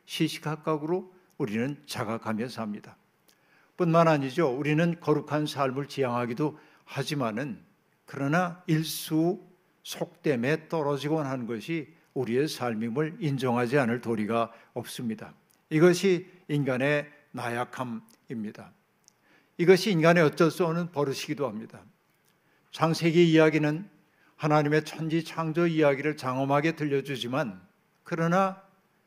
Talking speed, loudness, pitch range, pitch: 280 characters per minute, -27 LUFS, 135-170 Hz, 155 Hz